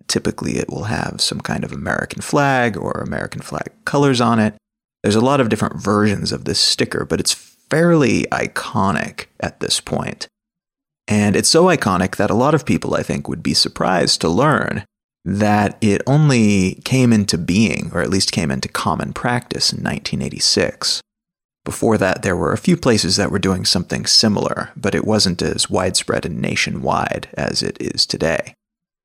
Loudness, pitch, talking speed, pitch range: -17 LUFS, 110 Hz, 175 wpm, 100-150 Hz